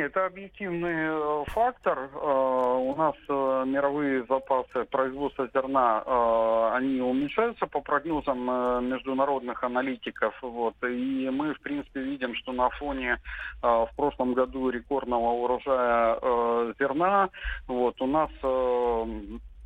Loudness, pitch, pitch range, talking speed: -27 LUFS, 130 Hz, 125-145 Hz, 95 wpm